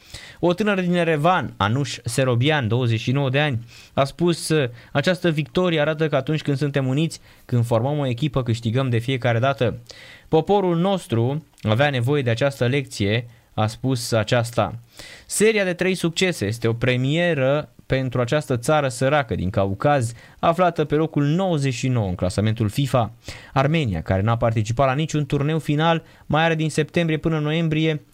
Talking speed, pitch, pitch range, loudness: 150 wpm, 140 Hz, 120-155 Hz, -21 LUFS